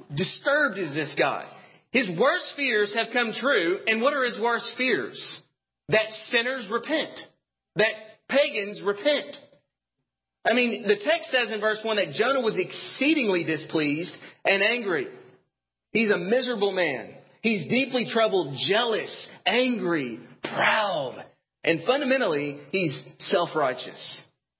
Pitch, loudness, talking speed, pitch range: 225 Hz, -25 LUFS, 125 wpm, 200-265 Hz